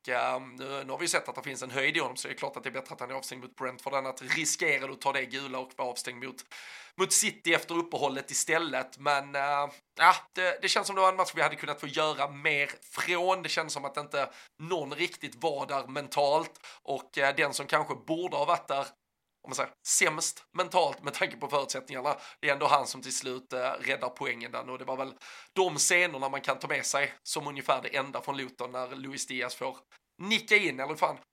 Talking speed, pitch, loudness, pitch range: 240 wpm, 145 Hz, -30 LUFS, 135-170 Hz